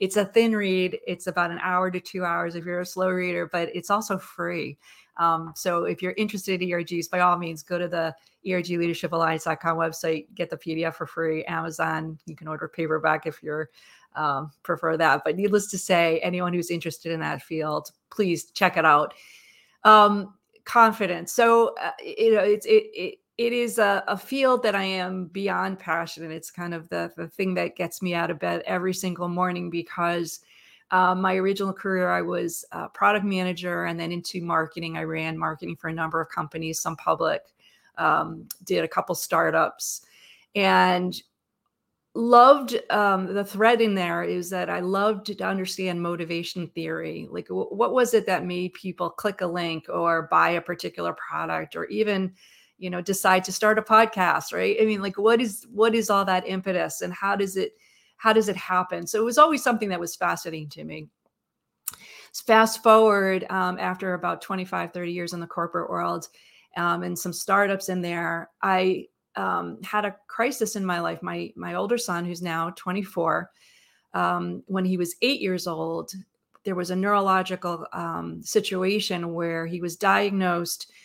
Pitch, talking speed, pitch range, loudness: 180 Hz, 185 wpm, 170-200 Hz, -24 LUFS